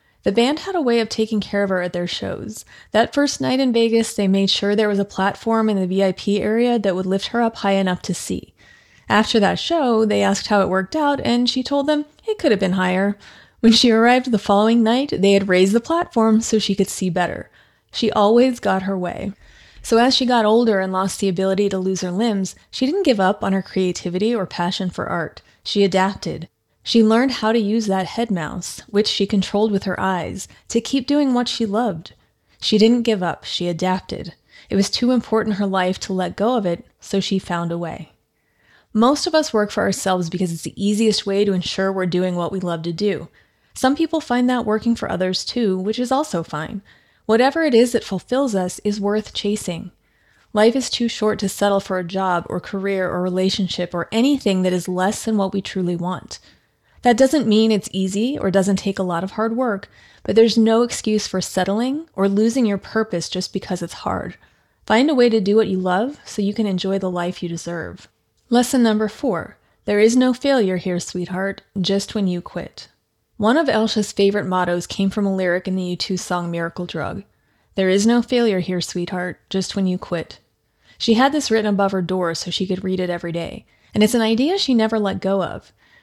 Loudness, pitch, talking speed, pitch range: -19 LUFS, 200 Hz, 220 wpm, 185-230 Hz